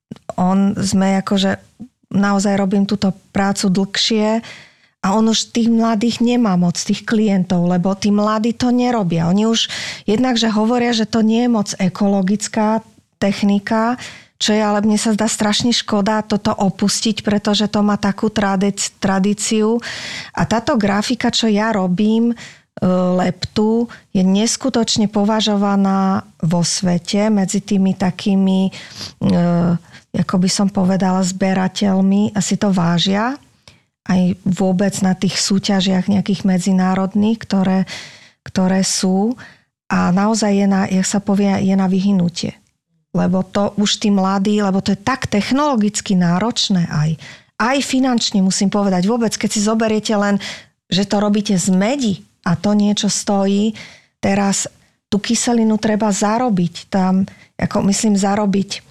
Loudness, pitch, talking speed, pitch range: -16 LUFS, 200 Hz, 140 wpm, 190-220 Hz